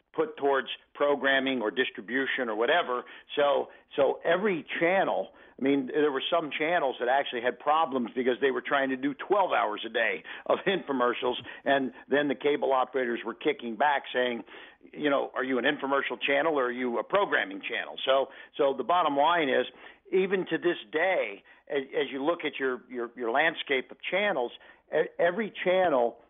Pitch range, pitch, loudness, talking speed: 125-150 Hz, 140 Hz, -28 LUFS, 180 wpm